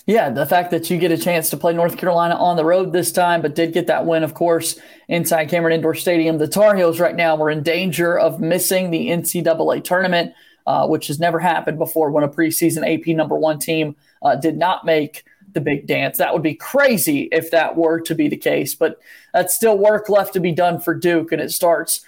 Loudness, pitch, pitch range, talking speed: -18 LUFS, 170 Hz, 160-180 Hz, 230 wpm